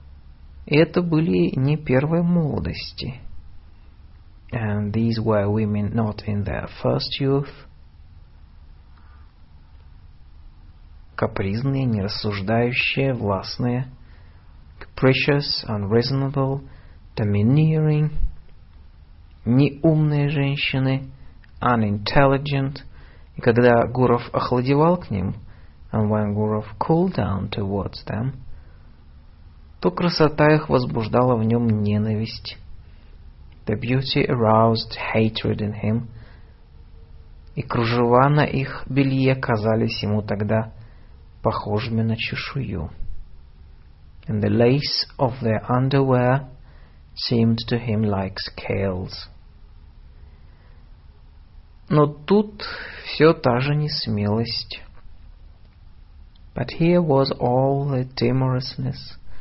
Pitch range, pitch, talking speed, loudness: 85-130 Hz, 110 Hz, 85 wpm, -21 LUFS